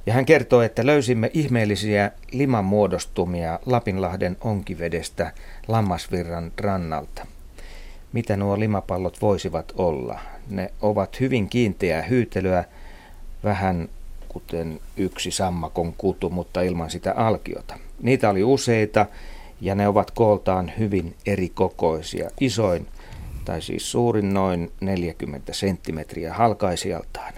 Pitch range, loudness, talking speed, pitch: 85-110 Hz, -23 LUFS, 105 wpm, 95 Hz